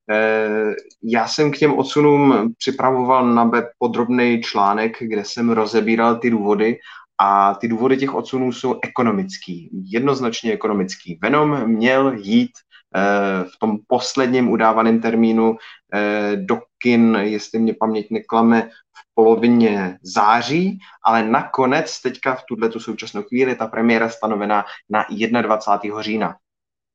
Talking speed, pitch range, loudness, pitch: 120 wpm, 110-130 Hz, -18 LUFS, 115 Hz